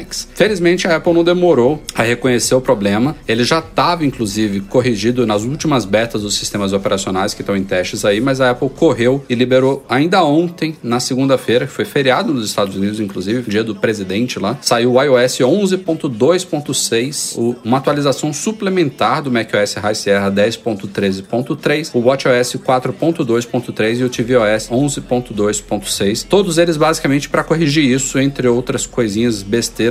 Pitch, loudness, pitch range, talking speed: 125 Hz, -15 LUFS, 110-150 Hz, 150 wpm